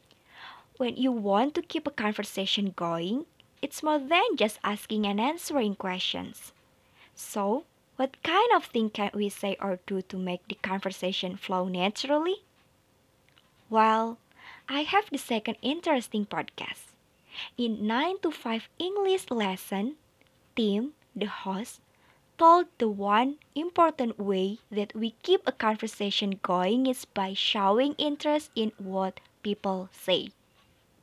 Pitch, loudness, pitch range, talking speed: 225 Hz, -29 LUFS, 200-290 Hz, 130 wpm